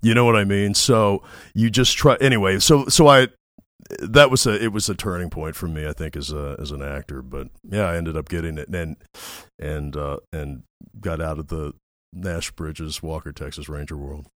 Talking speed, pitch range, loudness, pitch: 215 wpm, 75-105 Hz, -19 LUFS, 80 Hz